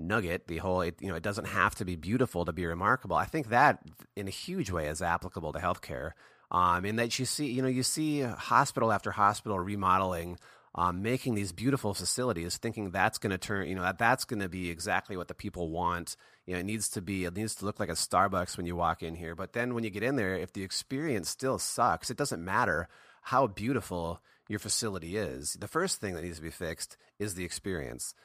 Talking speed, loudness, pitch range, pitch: 235 wpm, -32 LUFS, 90-110 Hz, 95 Hz